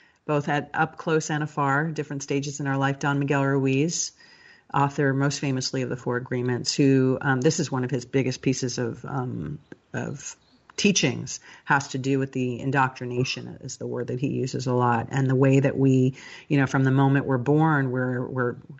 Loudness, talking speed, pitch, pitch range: -24 LUFS, 200 wpm, 135 Hz, 130-145 Hz